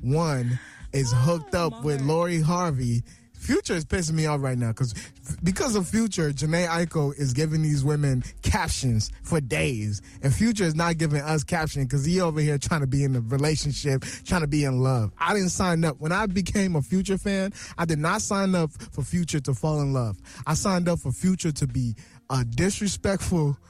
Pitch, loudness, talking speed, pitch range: 155 Hz, -25 LUFS, 205 wpm, 135-175 Hz